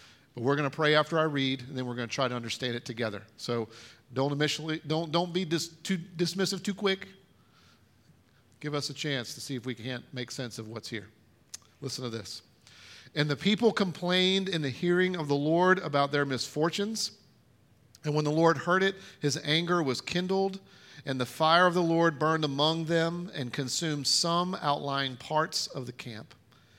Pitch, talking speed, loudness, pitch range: 145 Hz, 195 wpm, -29 LUFS, 125-170 Hz